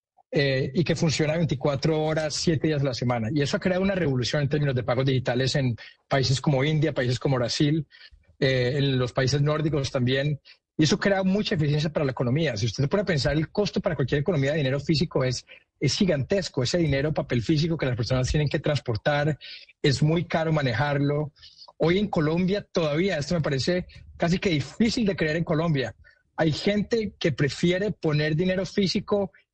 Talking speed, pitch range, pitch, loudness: 190 wpm, 135-175 Hz, 155 Hz, -25 LUFS